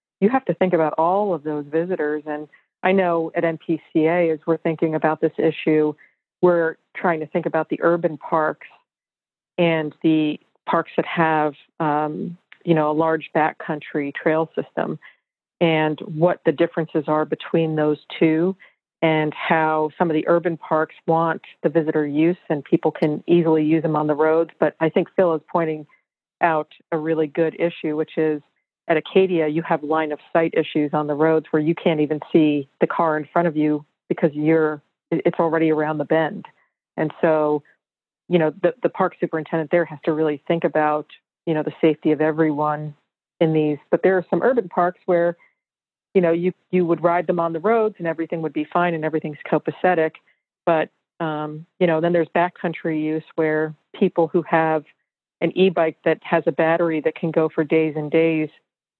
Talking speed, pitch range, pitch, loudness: 185 wpm, 155-170 Hz, 160 Hz, -21 LUFS